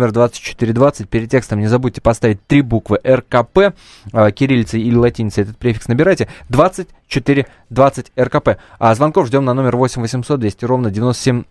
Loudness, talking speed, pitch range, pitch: -15 LUFS, 140 wpm, 115-135 Hz, 120 Hz